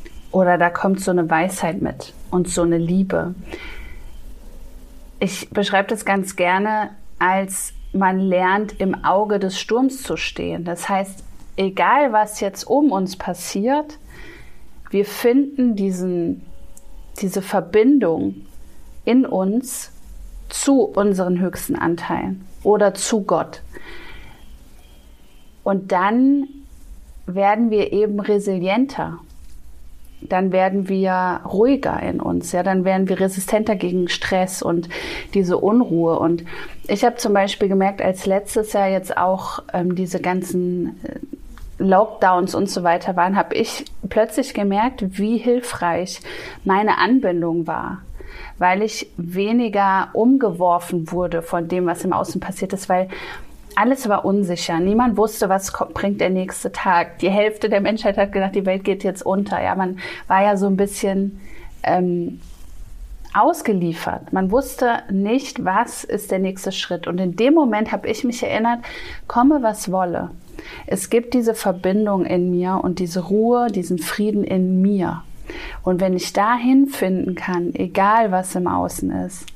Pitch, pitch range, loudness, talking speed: 195 Hz, 180-215 Hz, -19 LUFS, 140 wpm